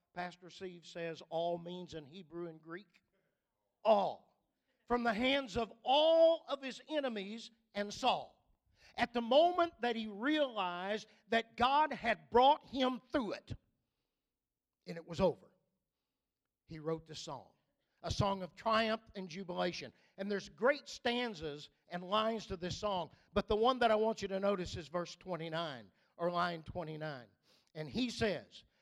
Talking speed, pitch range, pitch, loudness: 155 wpm, 170-240 Hz, 200 Hz, -36 LUFS